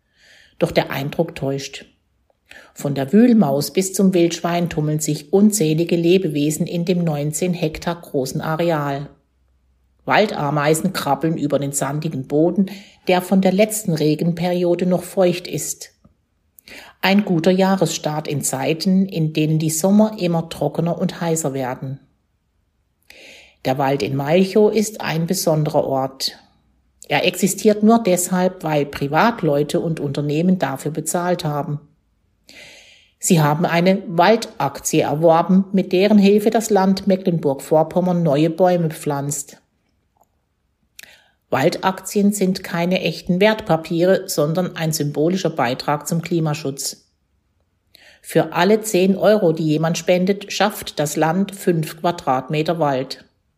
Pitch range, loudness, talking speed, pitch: 145-185 Hz, -18 LUFS, 120 wpm, 165 Hz